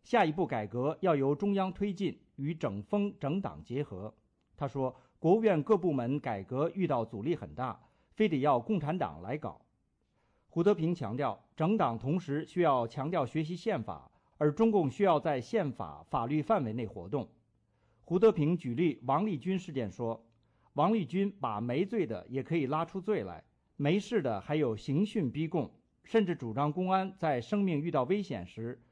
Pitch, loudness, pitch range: 150 Hz, -32 LUFS, 120-190 Hz